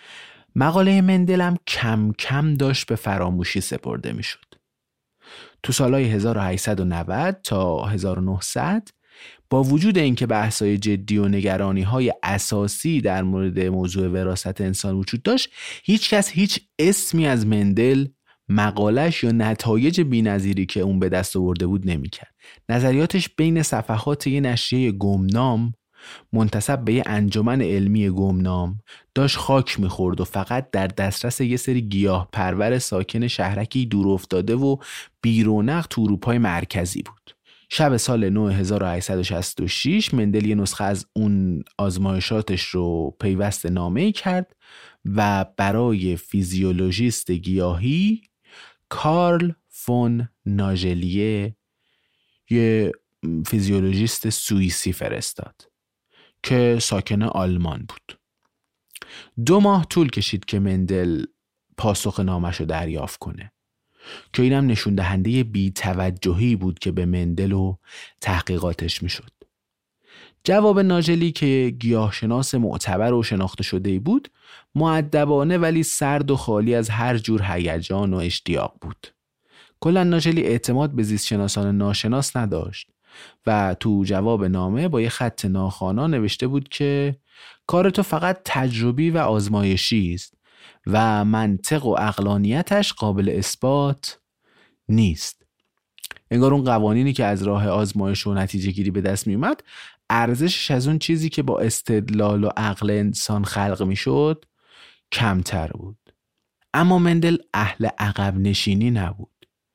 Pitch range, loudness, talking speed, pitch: 95-130 Hz, -21 LUFS, 120 wpm, 105 Hz